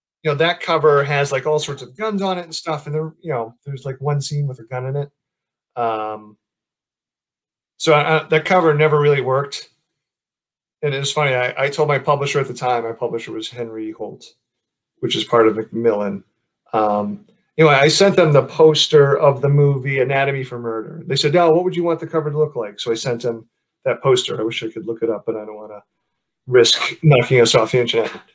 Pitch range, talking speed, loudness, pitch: 115-155 Hz, 225 wpm, -17 LUFS, 140 Hz